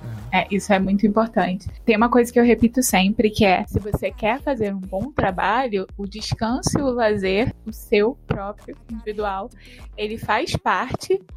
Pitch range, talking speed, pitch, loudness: 195-230 Hz, 175 wpm, 215 Hz, -21 LUFS